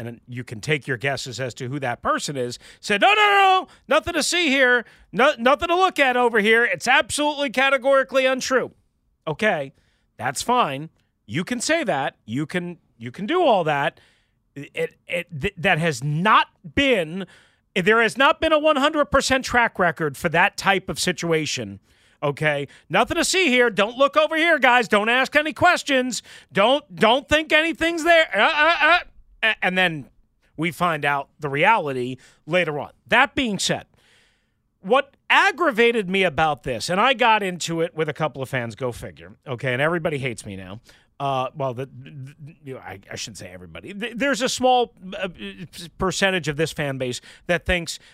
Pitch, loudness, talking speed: 180 Hz, -20 LUFS, 180 wpm